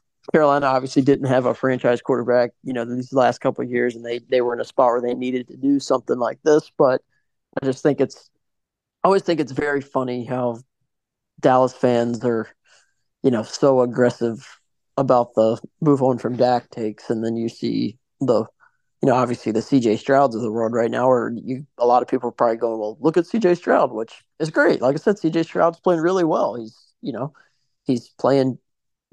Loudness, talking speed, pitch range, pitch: -20 LUFS, 210 wpm, 120-140 Hz, 125 Hz